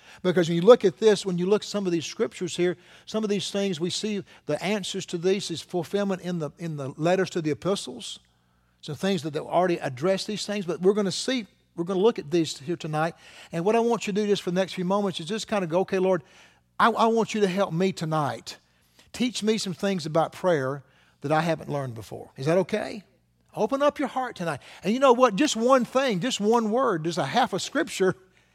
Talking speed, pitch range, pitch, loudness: 250 wpm, 165-210 Hz, 185 Hz, -25 LUFS